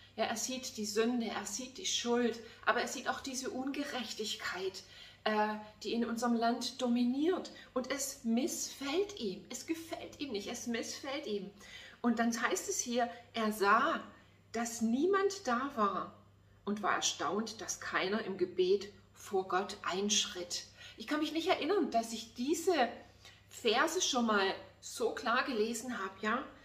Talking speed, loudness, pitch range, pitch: 155 wpm, -35 LUFS, 215-285 Hz, 240 Hz